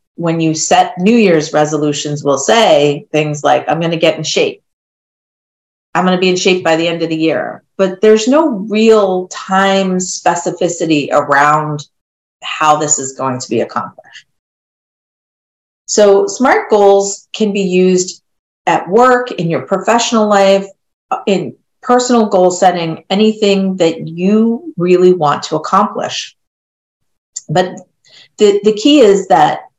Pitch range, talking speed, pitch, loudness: 155-205 Hz, 145 wpm, 185 Hz, -12 LUFS